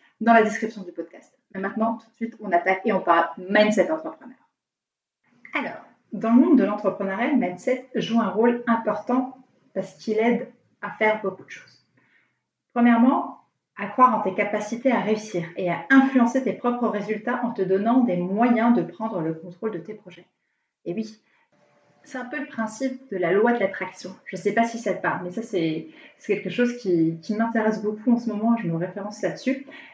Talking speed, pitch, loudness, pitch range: 200 wpm, 220 Hz, -23 LUFS, 195-240 Hz